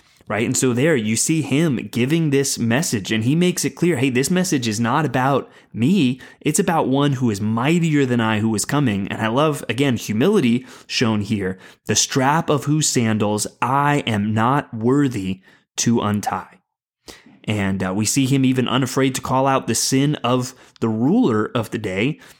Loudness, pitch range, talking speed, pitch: -19 LUFS, 110-140 Hz, 185 wpm, 125 Hz